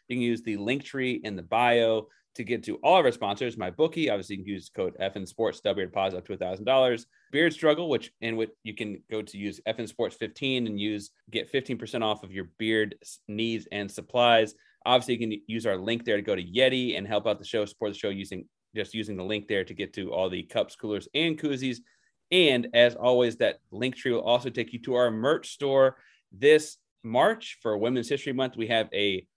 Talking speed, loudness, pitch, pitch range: 235 wpm, -27 LUFS, 115 Hz, 105-125 Hz